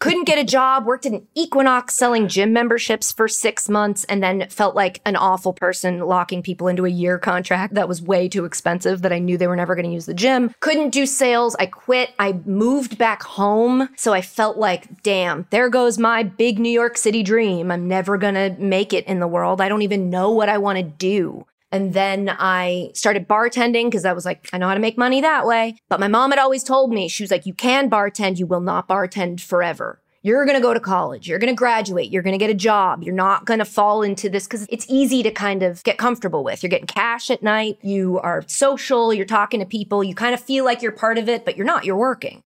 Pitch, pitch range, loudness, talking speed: 205 Hz, 185-235 Hz, -19 LUFS, 245 wpm